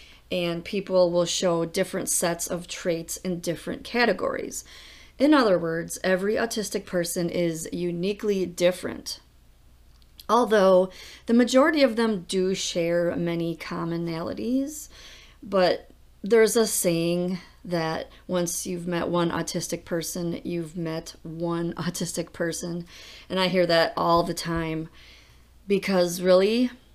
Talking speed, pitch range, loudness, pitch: 120 wpm, 170-190 Hz, -25 LUFS, 175 Hz